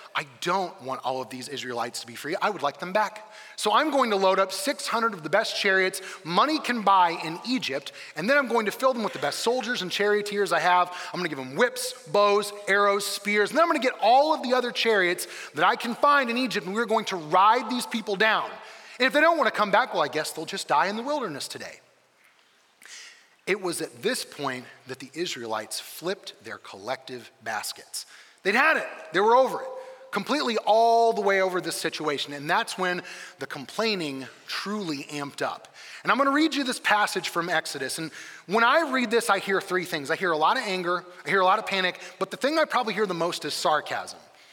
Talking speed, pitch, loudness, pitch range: 230 wpm, 200 Hz, -25 LUFS, 170-240 Hz